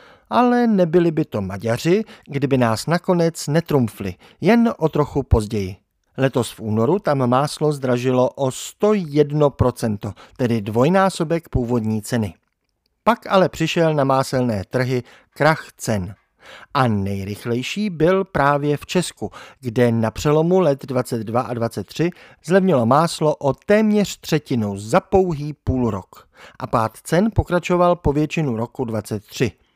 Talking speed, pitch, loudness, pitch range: 125 wpm, 135 Hz, -19 LUFS, 115-170 Hz